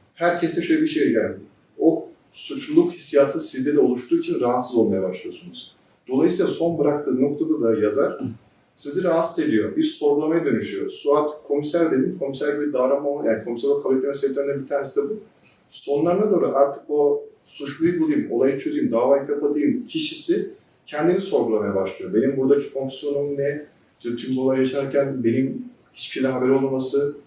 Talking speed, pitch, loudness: 150 wpm, 145 Hz, -22 LUFS